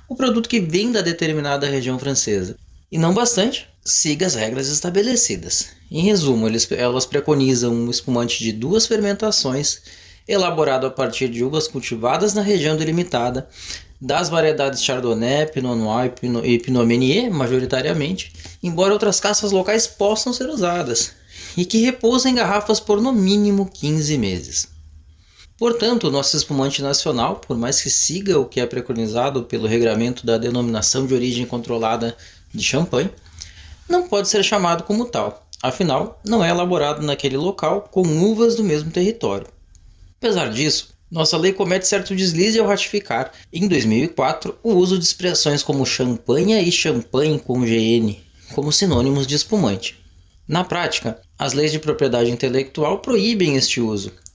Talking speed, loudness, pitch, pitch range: 145 wpm, -19 LUFS, 145 Hz, 120-195 Hz